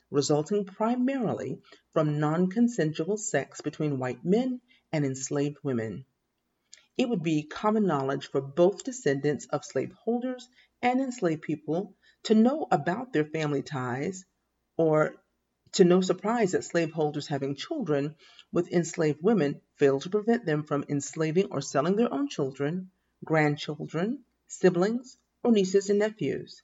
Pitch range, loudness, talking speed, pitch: 145-210 Hz, -28 LUFS, 135 wpm, 170 Hz